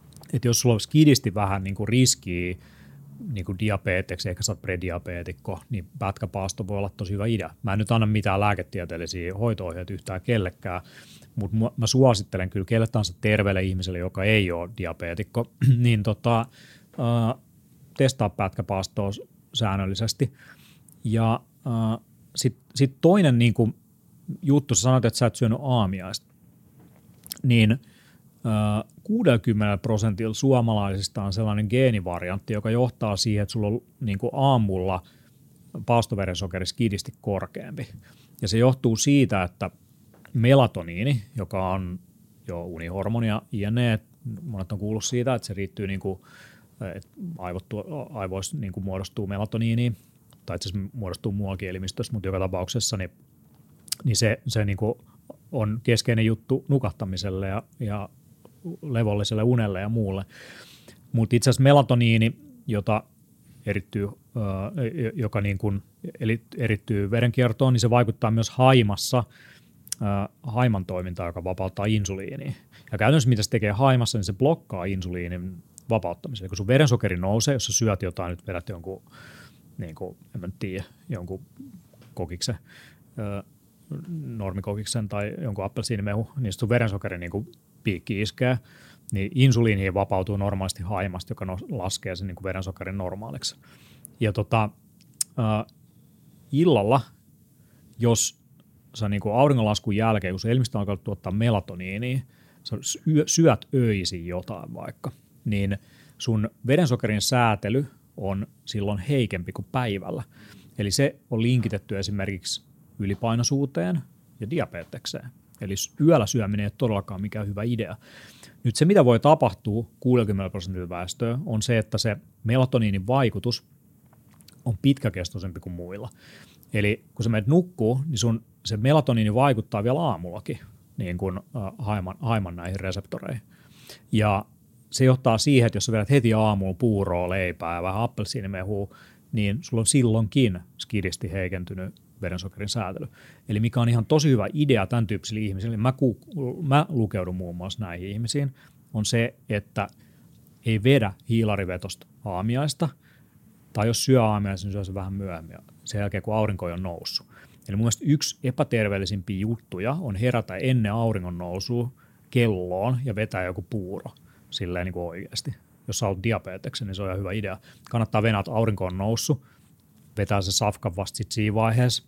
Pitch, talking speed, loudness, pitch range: 110 Hz, 135 wpm, -25 LUFS, 100-125 Hz